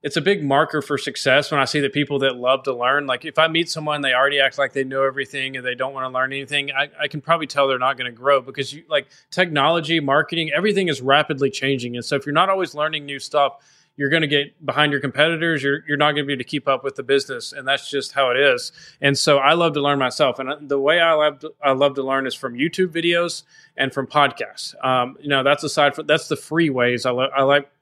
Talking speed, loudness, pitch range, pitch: 270 wpm, -20 LUFS, 135-155 Hz, 145 Hz